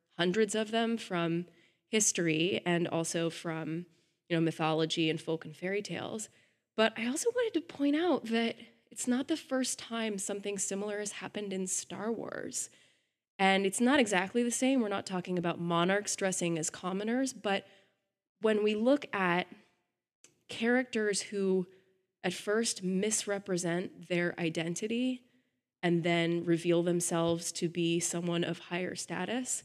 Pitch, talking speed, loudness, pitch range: 190 Hz, 145 wpm, -32 LUFS, 170-220 Hz